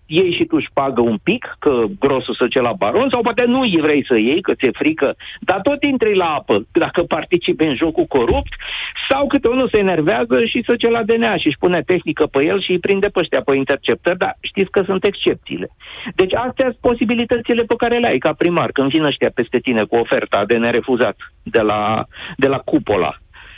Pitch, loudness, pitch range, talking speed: 200 Hz, -17 LUFS, 150-255 Hz, 220 wpm